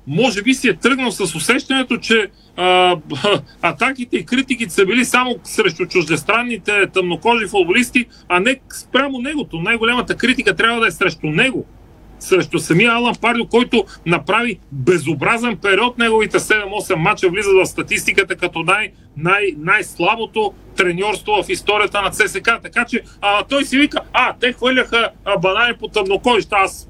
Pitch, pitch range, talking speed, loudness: 215 Hz, 185-245 Hz, 150 wpm, -16 LUFS